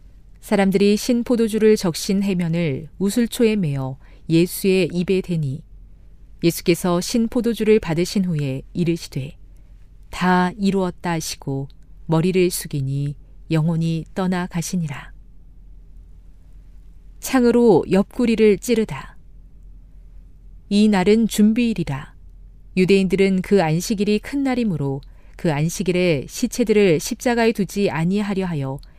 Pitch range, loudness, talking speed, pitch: 135-205 Hz, -20 LUFS, 255 characters per minute, 175 Hz